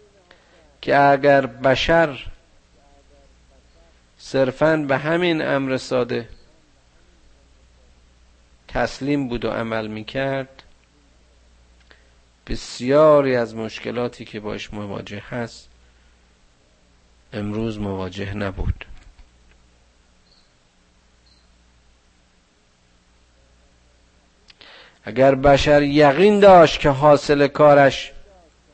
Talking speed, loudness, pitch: 65 wpm, -18 LUFS, 95 Hz